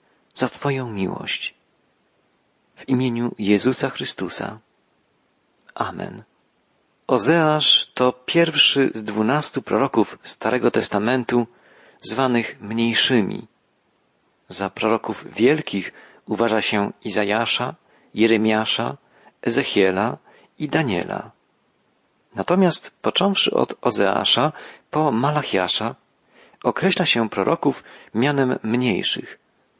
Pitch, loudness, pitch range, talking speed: 120 Hz, -20 LUFS, 110-135 Hz, 80 wpm